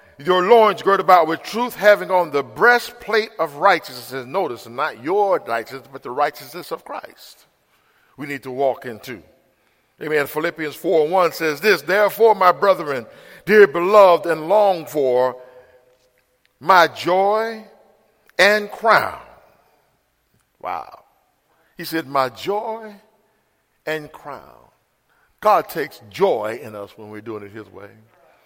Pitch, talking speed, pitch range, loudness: 165 Hz, 135 wpm, 135-205 Hz, -18 LUFS